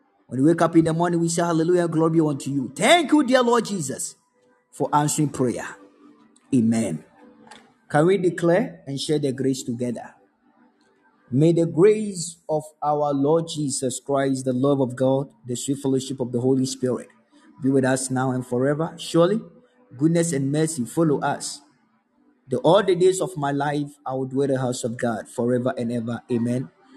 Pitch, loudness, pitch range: 140 Hz, -22 LUFS, 130-170 Hz